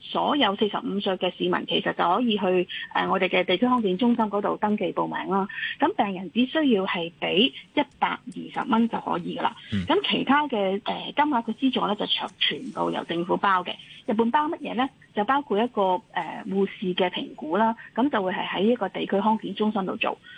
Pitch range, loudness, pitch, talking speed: 195-250 Hz, -25 LUFS, 215 Hz, 310 characters per minute